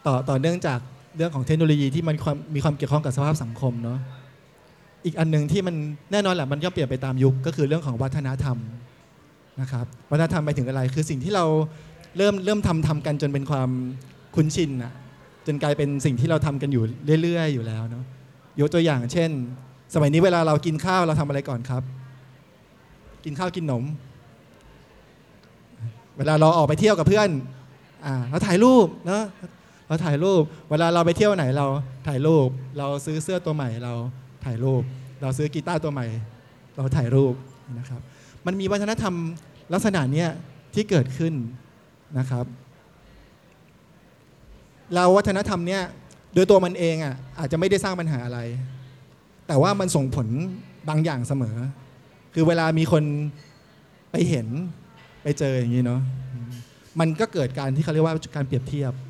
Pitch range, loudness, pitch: 130-165 Hz, -23 LUFS, 145 Hz